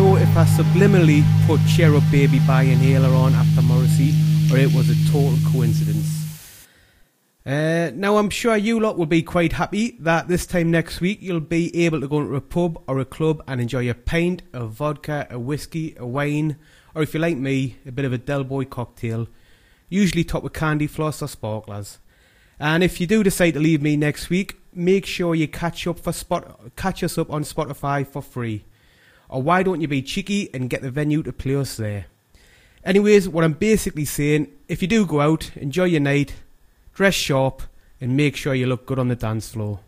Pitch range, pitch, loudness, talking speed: 135-170 Hz, 150 Hz, -20 LUFS, 205 wpm